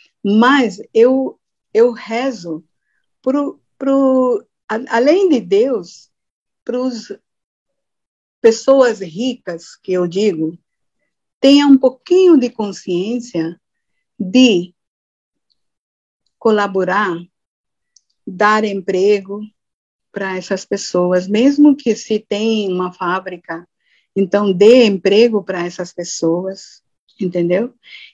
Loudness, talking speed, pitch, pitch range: -15 LUFS, 85 wpm, 210 Hz, 185-250 Hz